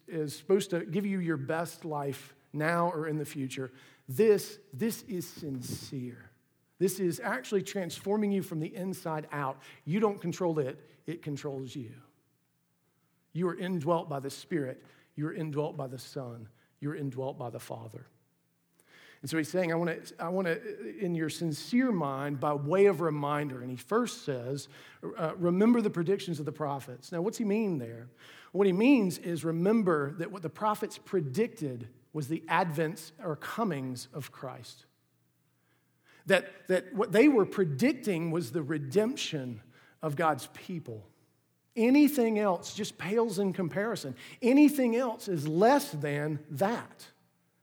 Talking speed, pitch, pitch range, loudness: 155 wpm, 160 Hz, 140-195 Hz, -31 LUFS